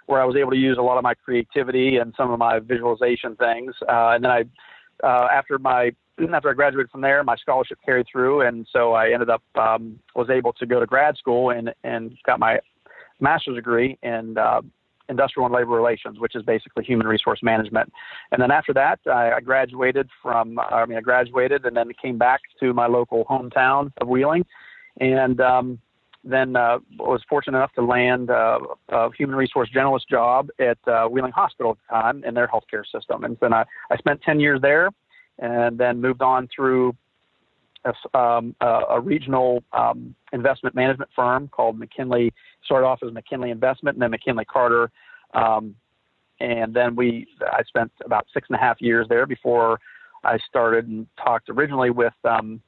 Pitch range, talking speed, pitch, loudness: 115-130 Hz, 190 wpm, 125 Hz, -21 LUFS